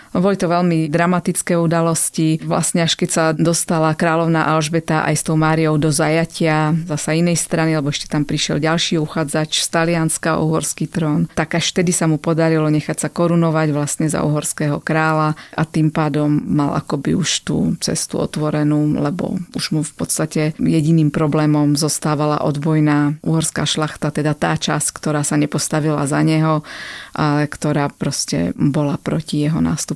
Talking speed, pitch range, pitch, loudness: 160 wpm, 150-165 Hz, 155 Hz, -17 LUFS